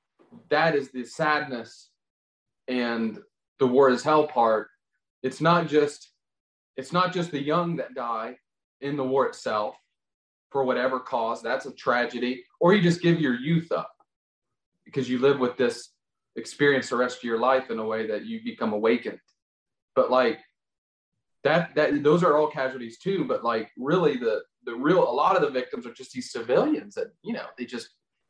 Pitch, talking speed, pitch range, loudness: 135 Hz, 180 wpm, 125-165 Hz, -25 LUFS